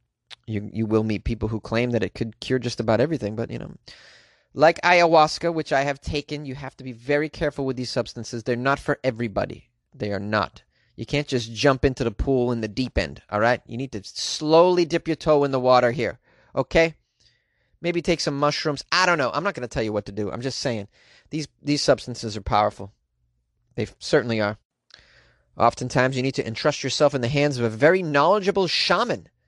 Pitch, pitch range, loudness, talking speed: 125 Hz, 110-145 Hz, -23 LUFS, 215 wpm